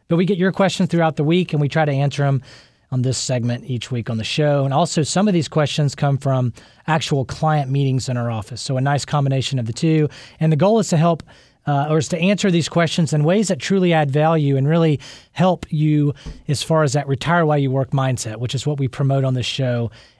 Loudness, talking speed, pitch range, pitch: -19 LUFS, 245 wpm, 130-160 Hz, 145 Hz